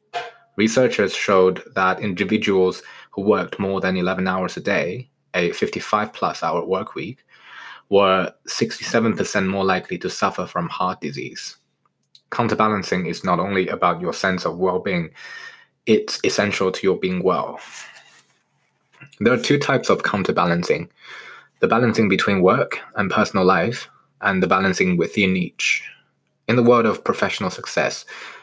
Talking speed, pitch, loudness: 140 wpm, 110 Hz, -20 LUFS